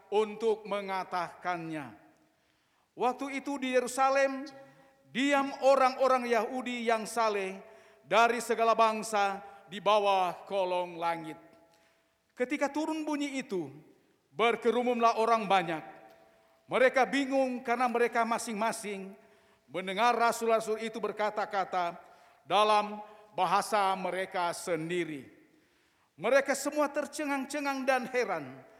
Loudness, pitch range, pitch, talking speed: -30 LUFS, 190-255 Hz, 220 Hz, 90 wpm